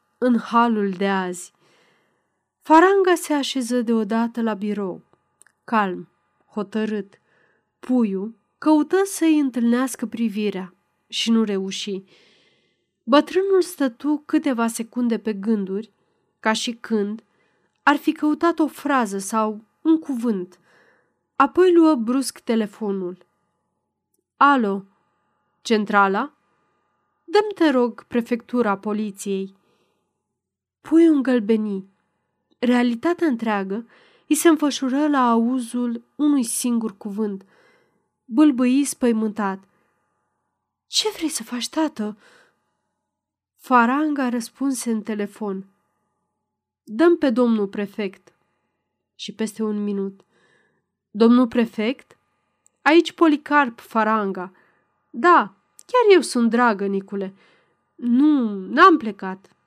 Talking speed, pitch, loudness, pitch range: 95 wpm, 235 Hz, -20 LUFS, 210-285 Hz